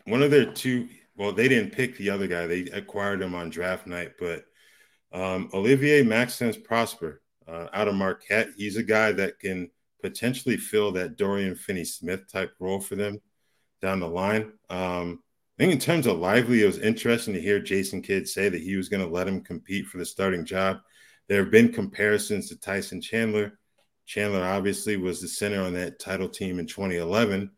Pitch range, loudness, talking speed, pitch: 95-110 Hz, -26 LUFS, 195 wpm, 100 Hz